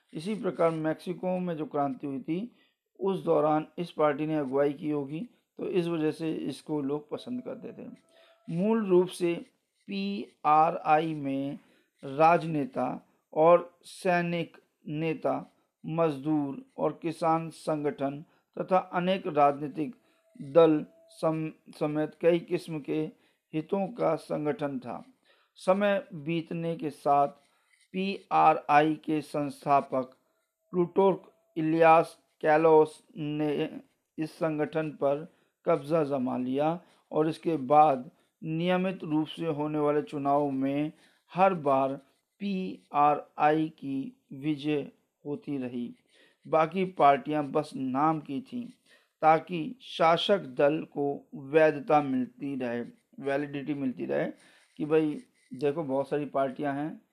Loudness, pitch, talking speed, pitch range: -29 LUFS, 155 Hz, 115 wpm, 145-180 Hz